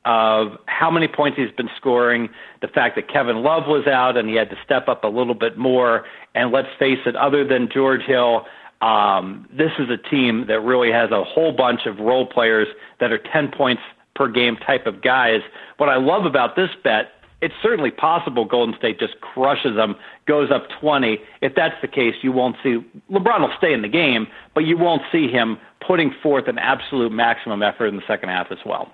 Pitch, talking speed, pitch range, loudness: 125 Hz, 210 wpm, 115-140 Hz, -19 LUFS